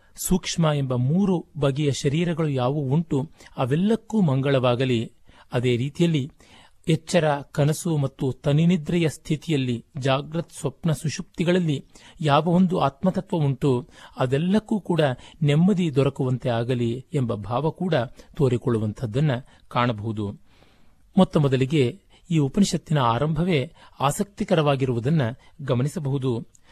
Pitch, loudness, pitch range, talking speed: 145 Hz, -23 LUFS, 125-170 Hz, 90 wpm